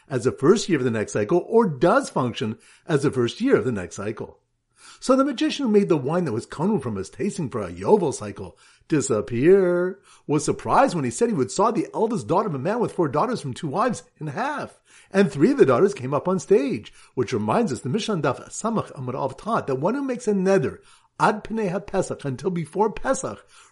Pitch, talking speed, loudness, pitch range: 185 Hz, 220 wpm, -23 LUFS, 145-210 Hz